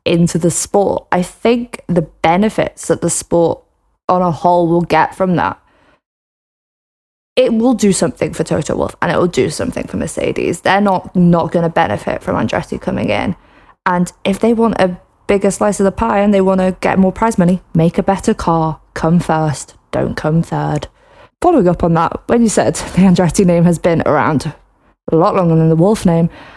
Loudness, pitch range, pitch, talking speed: -14 LUFS, 165-200 Hz, 180 Hz, 200 wpm